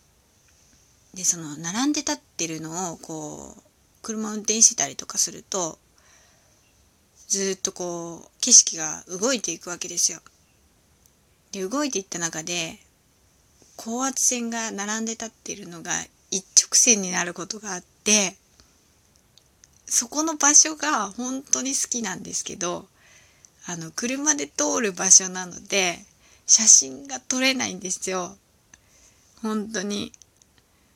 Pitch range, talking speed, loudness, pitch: 175-245 Hz, 235 characters per minute, -21 LUFS, 205 Hz